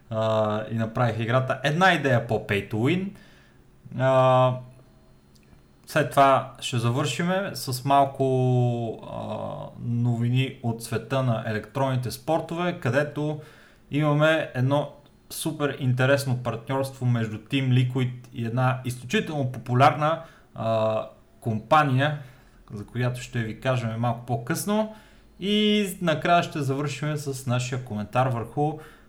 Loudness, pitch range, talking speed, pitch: -25 LUFS, 120-150 Hz, 110 wpm, 130 Hz